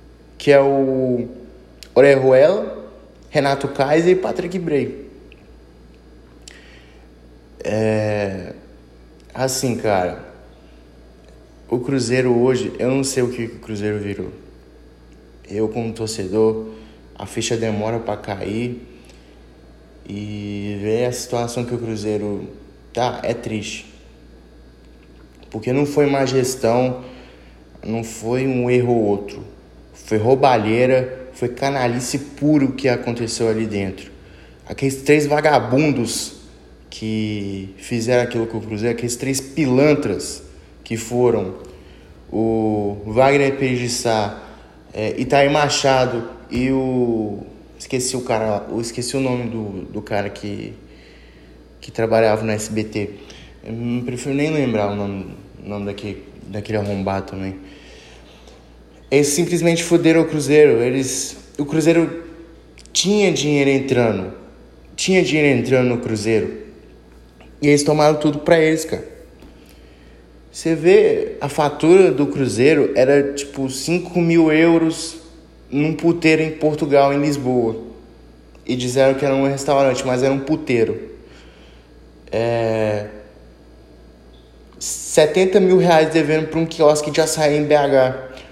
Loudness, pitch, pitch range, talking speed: -18 LUFS, 115 Hz, 95-140 Hz, 115 wpm